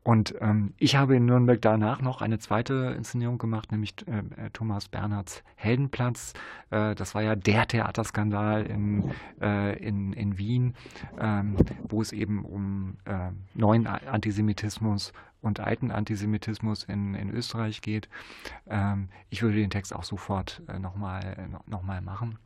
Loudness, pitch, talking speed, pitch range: -29 LUFS, 105 Hz, 145 wpm, 100-110 Hz